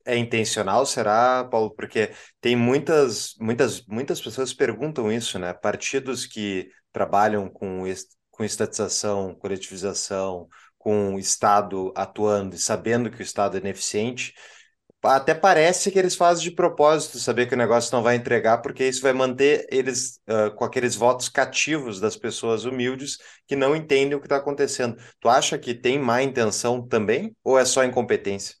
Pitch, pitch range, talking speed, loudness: 120 Hz, 105-135 Hz, 165 wpm, -23 LUFS